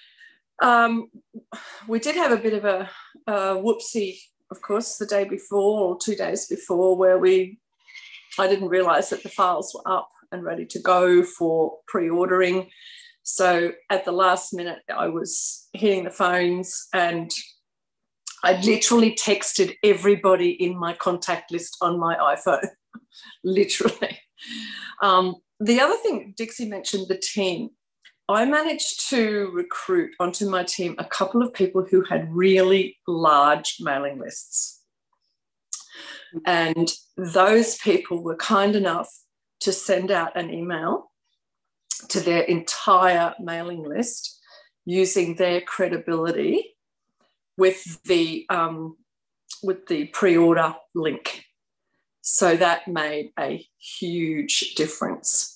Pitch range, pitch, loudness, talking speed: 175-225 Hz, 190 Hz, -22 LUFS, 125 wpm